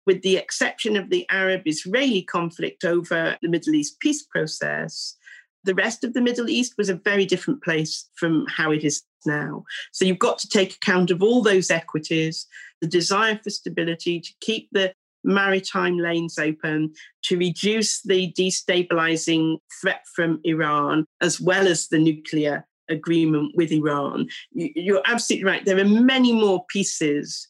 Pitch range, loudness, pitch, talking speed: 165-205 Hz, -22 LUFS, 185 Hz, 160 wpm